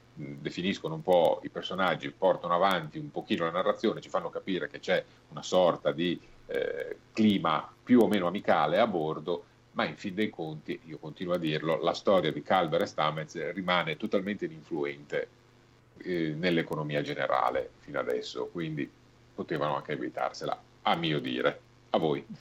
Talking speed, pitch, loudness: 160 wpm, 100 Hz, -30 LUFS